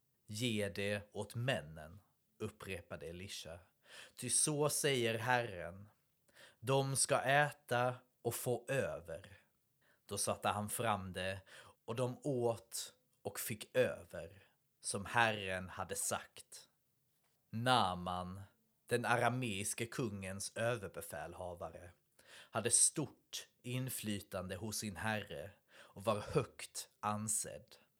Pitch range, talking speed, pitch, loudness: 100-125 Hz, 100 wpm, 110 Hz, -38 LUFS